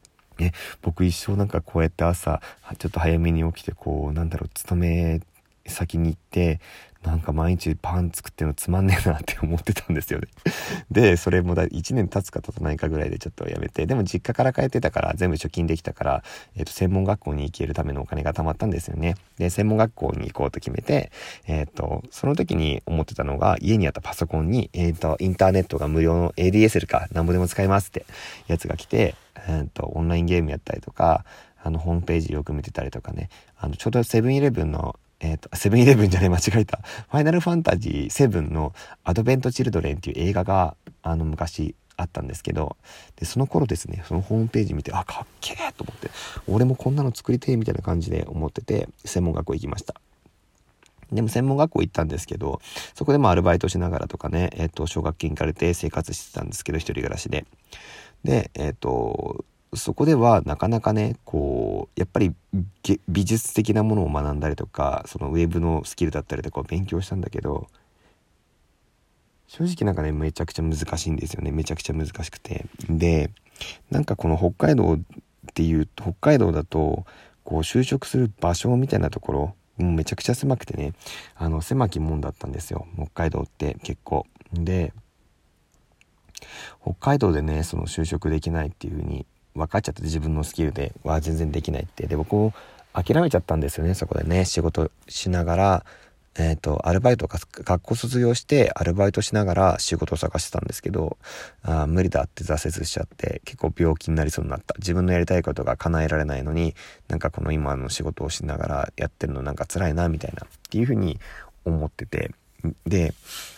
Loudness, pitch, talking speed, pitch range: -24 LUFS, 85 Hz, 405 characters per minute, 80-95 Hz